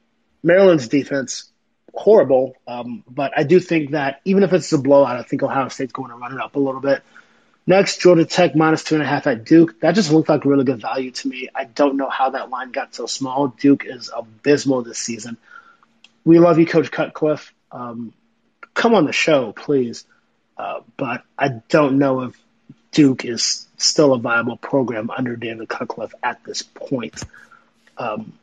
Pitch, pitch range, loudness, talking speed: 140 Hz, 130-160 Hz, -18 LUFS, 190 wpm